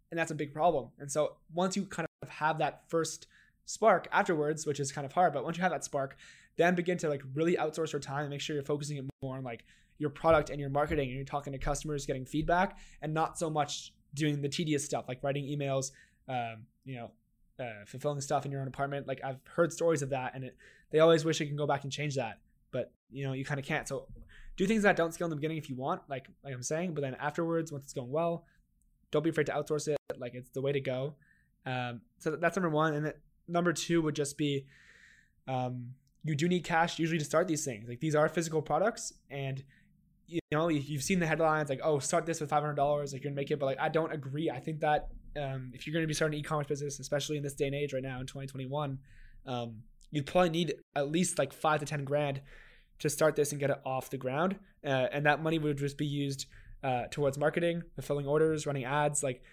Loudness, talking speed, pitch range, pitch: -33 LUFS, 250 wpm, 135-160 Hz, 145 Hz